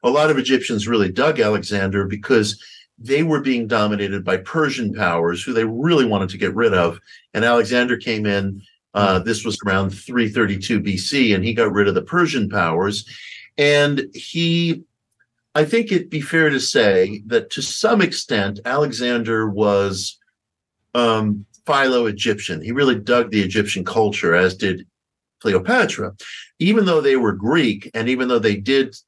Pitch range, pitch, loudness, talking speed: 100-135 Hz, 115 Hz, -19 LUFS, 160 wpm